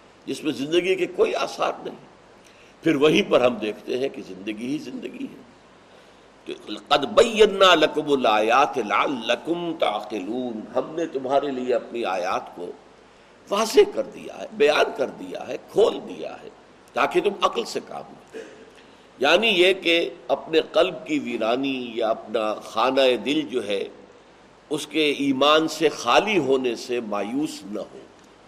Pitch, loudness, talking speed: 155 Hz, -22 LUFS, 150 wpm